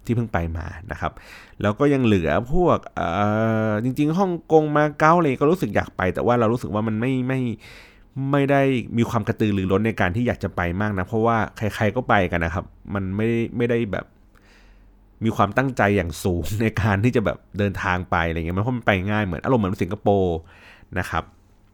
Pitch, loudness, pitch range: 105 Hz, -22 LUFS, 95-120 Hz